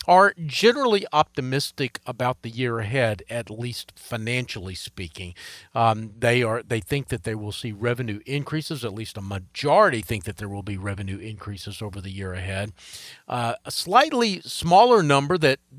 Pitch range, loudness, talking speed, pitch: 105-140 Hz, -23 LUFS, 165 wpm, 115 Hz